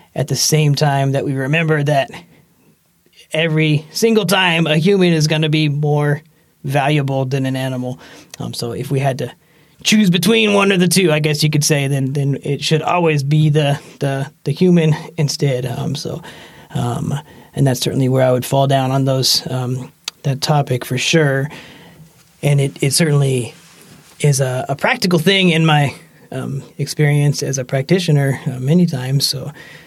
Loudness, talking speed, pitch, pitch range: -16 LUFS, 175 wpm, 150 Hz, 135-160 Hz